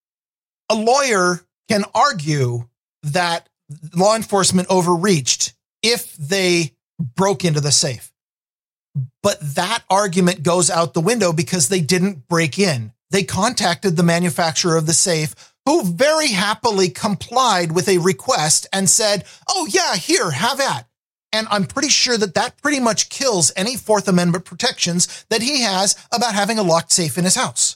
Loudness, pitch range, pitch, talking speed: -17 LUFS, 170-215 Hz, 185 Hz, 155 wpm